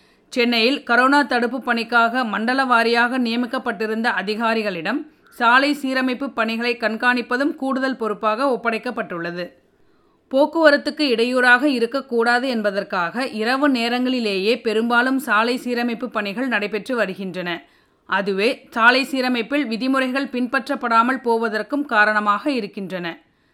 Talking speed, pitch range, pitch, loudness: 90 wpm, 220-260 Hz, 240 Hz, -19 LUFS